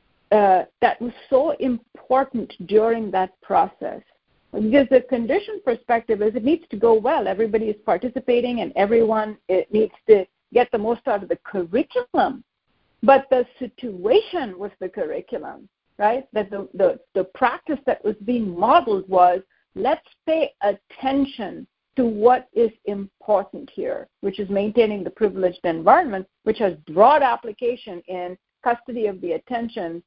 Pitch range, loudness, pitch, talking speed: 200-255 Hz, -21 LUFS, 225 Hz, 145 wpm